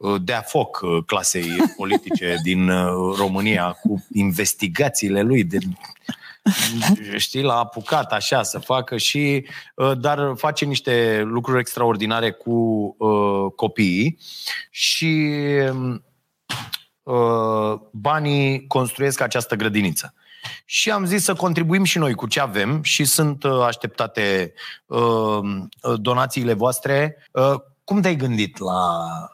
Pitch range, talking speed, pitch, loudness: 105-145 Hz, 105 wpm, 125 Hz, -20 LUFS